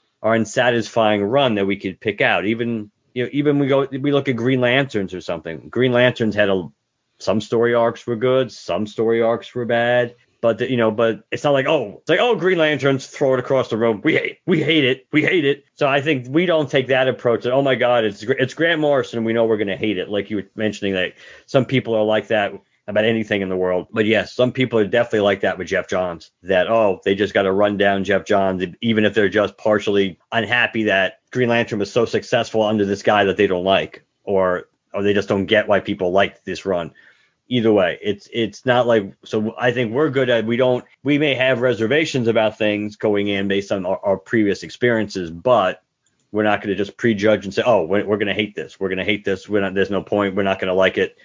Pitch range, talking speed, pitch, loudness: 100-130 Hz, 245 wpm, 115 Hz, -19 LUFS